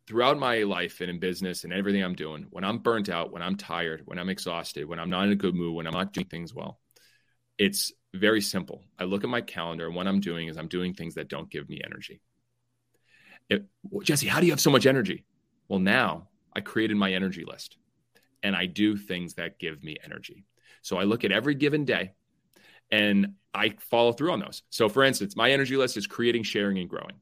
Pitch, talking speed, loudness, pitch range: 100 Hz, 225 wpm, -27 LUFS, 90-120 Hz